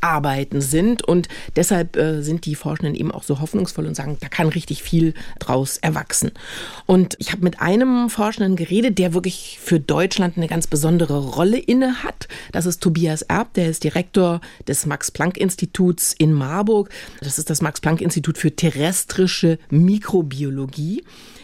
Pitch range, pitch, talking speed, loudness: 155-185 Hz, 170 Hz, 150 wpm, -19 LUFS